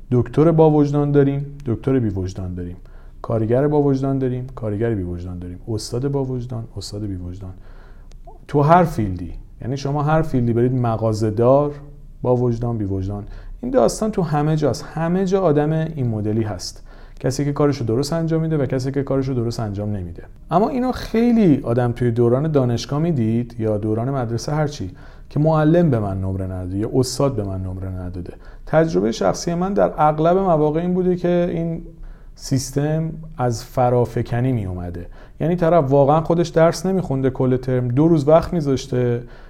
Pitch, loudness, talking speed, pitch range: 130 Hz, -19 LUFS, 165 wpm, 110-155 Hz